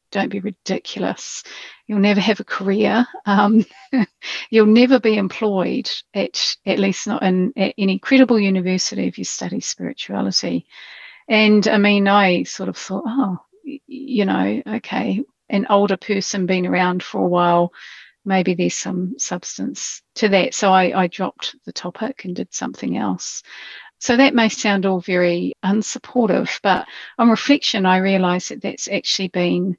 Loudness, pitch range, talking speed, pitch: -18 LUFS, 185-225 Hz, 155 wpm, 200 Hz